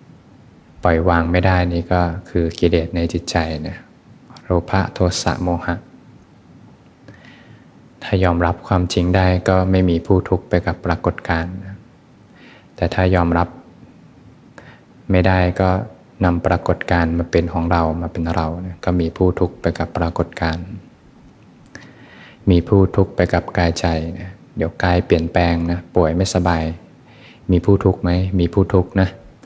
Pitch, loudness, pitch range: 90 Hz, -18 LUFS, 85-95 Hz